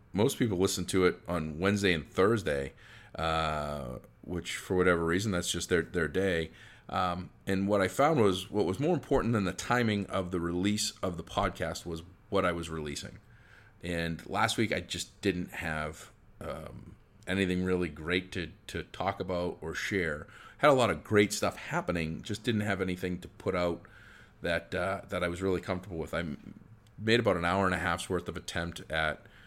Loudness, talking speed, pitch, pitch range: -31 LUFS, 190 wpm, 90 Hz, 85-100 Hz